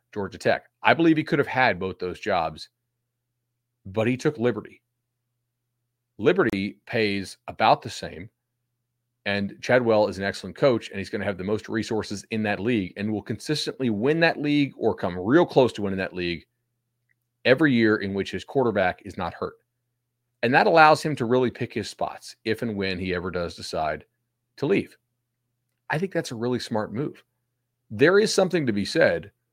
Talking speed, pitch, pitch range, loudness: 185 wpm, 120 Hz, 105-125 Hz, -24 LUFS